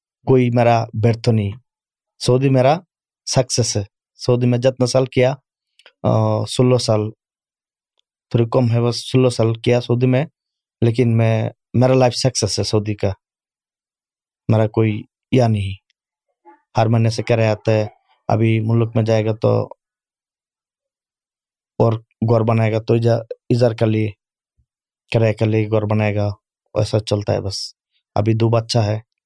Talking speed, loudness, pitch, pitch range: 145 wpm, -18 LUFS, 115 Hz, 110-125 Hz